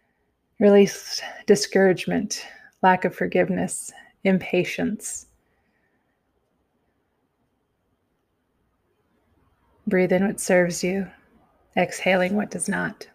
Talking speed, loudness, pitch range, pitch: 70 wpm, -22 LUFS, 185-210 Hz, 190 Hz